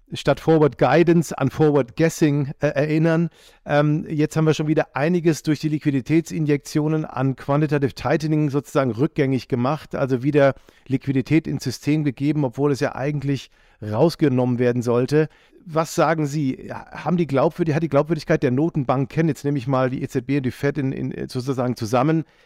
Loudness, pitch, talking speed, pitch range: -21 LUFS, 145 Hz, 165 wpm, 135-155 Hz